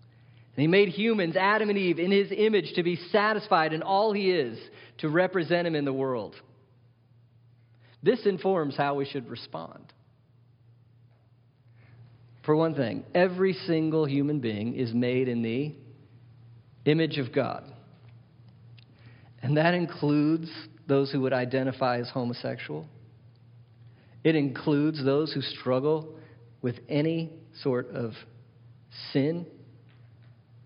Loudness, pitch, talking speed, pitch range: -27 LUFS, 130 Hz, 120 wpm, 120-155 Hz